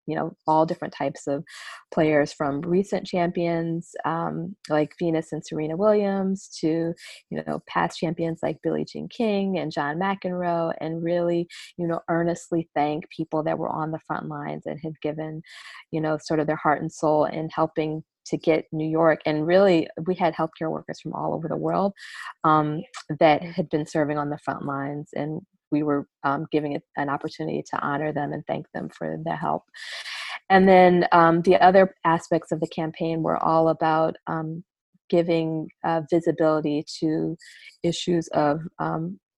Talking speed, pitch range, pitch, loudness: 175 wpm, 155-170 Hz, 160 Hz, -24 LUFS